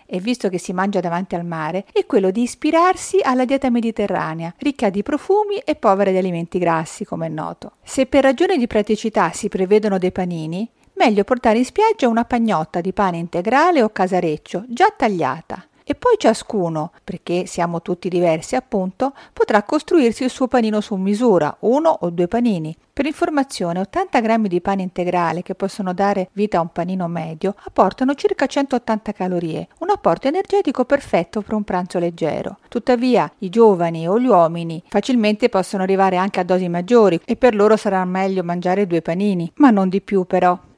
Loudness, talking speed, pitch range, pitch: -18 LUFS, 175 wpm, 180-250 Hz, 205 Hz